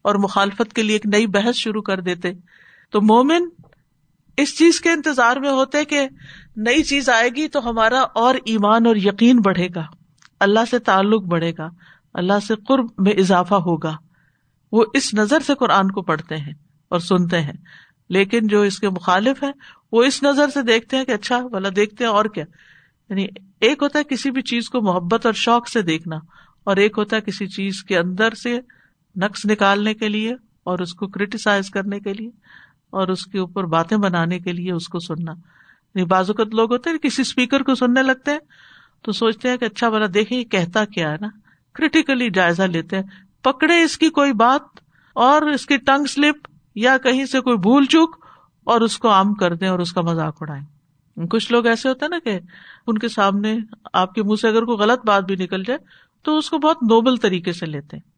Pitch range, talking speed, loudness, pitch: 185-250 Hz, 205 wpm, -18 LUFS, 215 Hz